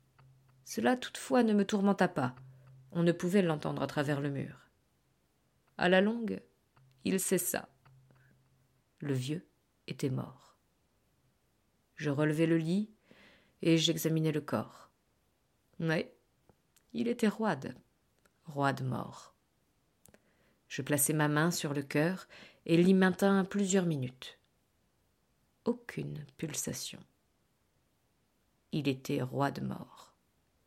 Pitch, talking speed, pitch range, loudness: 150 Hz, 110 wpm, 130-185 Hz, -32 LUFS